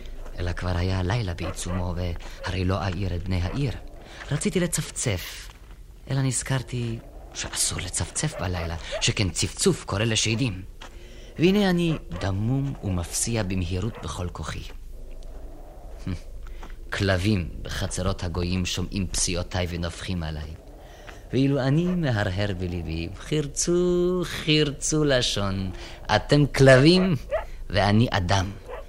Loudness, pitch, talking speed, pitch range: -25 LUFS, 95 Hz, 100 wpm, 90-130 Hz